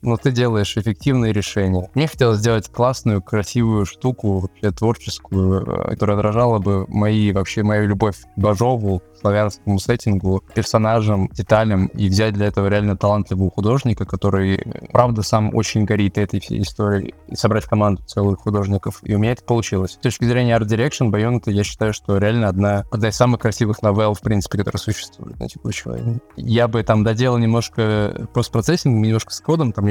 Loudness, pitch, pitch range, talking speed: -19 LUFS, 105 Hz, 100-115 Hz, 170 wpm